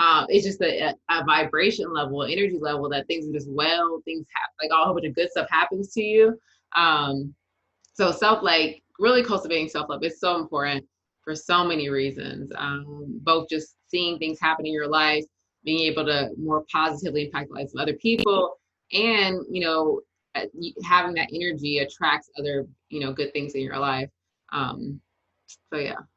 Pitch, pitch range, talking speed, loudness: 155 Hz, 145-175 Hz, 180 wpm, -24 LUFS